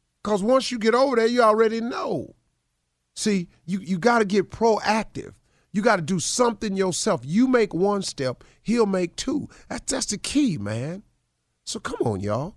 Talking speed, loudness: 180 wpm, -23 LUFS